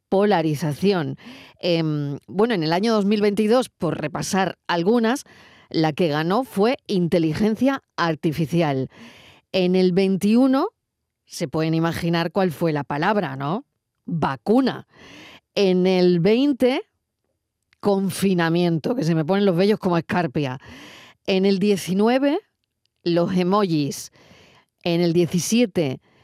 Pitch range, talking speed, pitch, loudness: 165-210 Hz, 110 wpm, 185 Hz, -21 LUFS